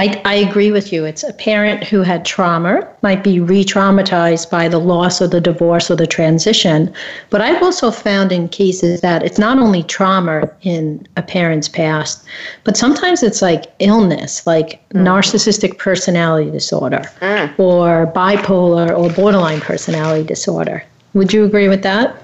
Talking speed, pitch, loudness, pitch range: 155 wpm, 185 Hz, -13 LUFS, 170-205 Hz